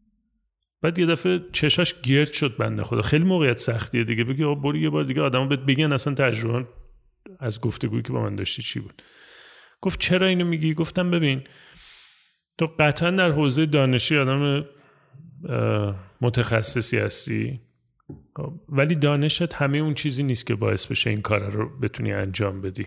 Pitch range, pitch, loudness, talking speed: 120-155 Hz, 140 Hz, -23 LUFS, 155 wpm